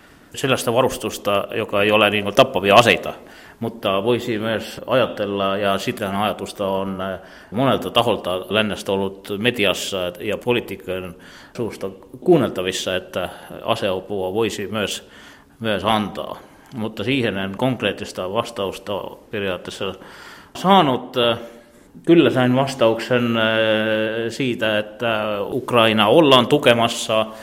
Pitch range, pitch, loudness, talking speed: 100-120 Hz, 110 Hz, -19 LUFS, 110 wpm